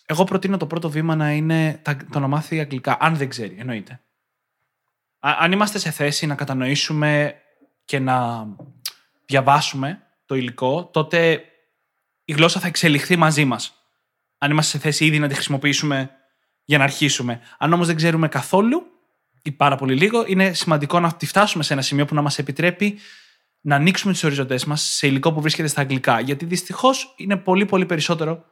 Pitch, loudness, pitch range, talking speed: 150 Hz, -19 LUFS, 140-170 Hz, 175 wpm